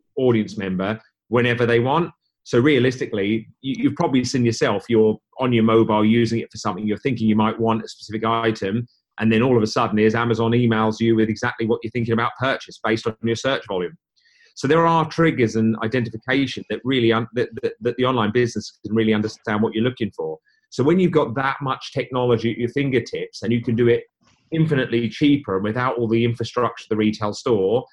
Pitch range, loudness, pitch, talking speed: 110-130 Hz, -21 LUFS, 115 Hz, 205 wpm